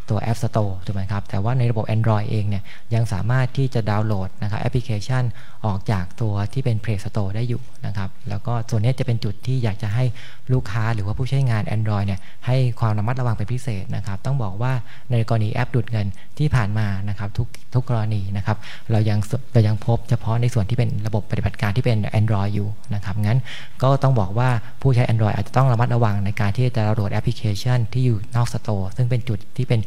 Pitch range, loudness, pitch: 105-125 Hz, -22 LUFS, 115 Hz